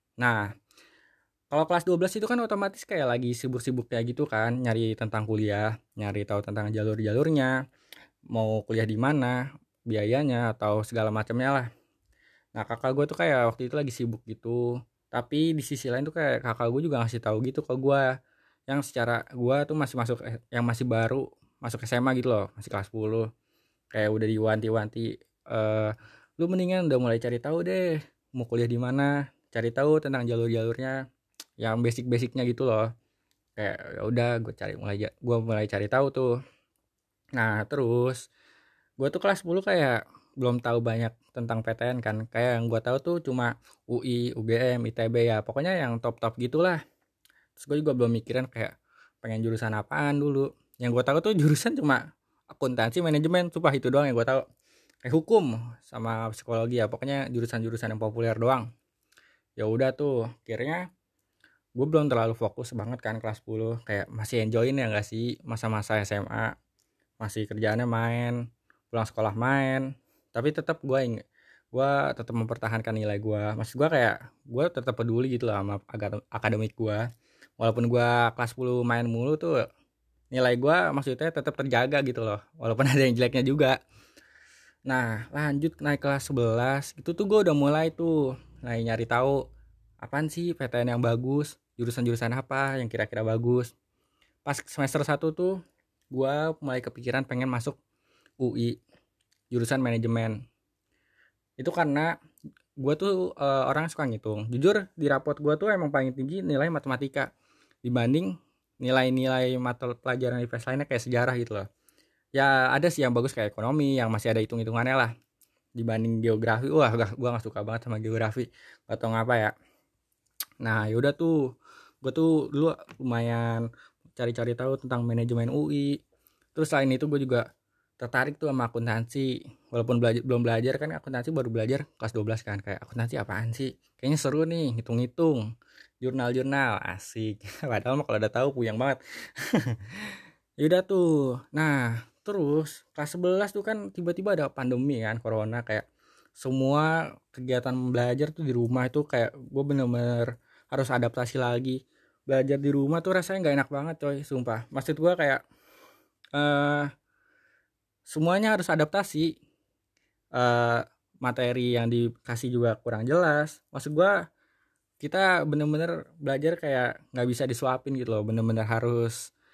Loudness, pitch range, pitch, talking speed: -28 LUFS, 115-140 Hz, 125 Hz, 155 wpm